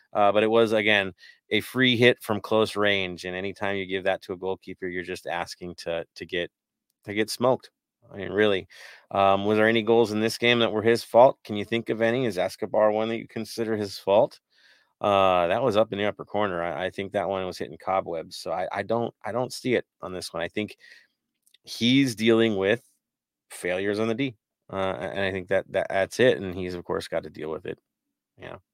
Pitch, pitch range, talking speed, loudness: 105 Hz, 95-115 Hz, 230 wpm, -25 LUFS